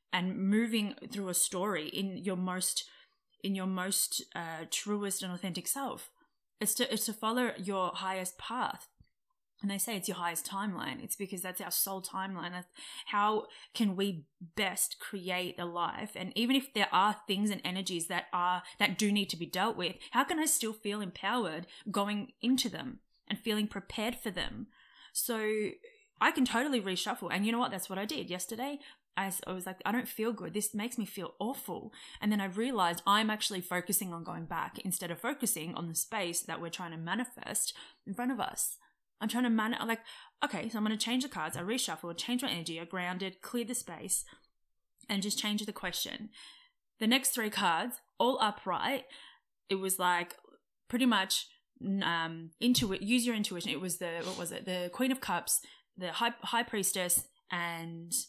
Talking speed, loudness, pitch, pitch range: 195 wpm, -34 LUFS, 200 Hz, 180-235 Hz